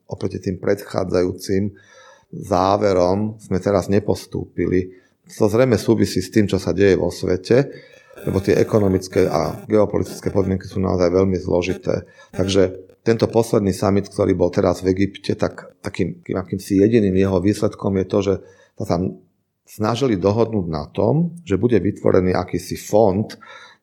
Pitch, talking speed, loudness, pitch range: 95 Hz, 145 wpm, -19 LUFS, 95-105 Hz